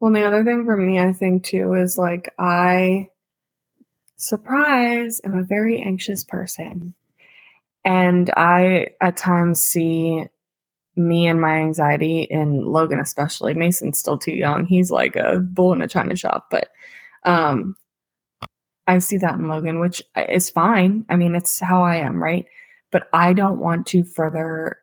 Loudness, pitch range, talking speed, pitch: -19 LUFS, 165-190 Hz, 160 wpm, 180 Hz